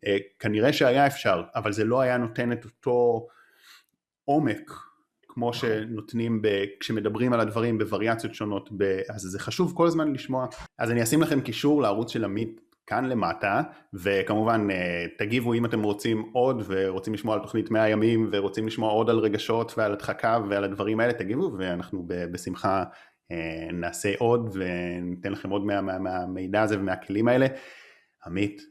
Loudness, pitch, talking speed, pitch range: -26 LUFS, 110 Hz, 150 wpm, 100-115 Hz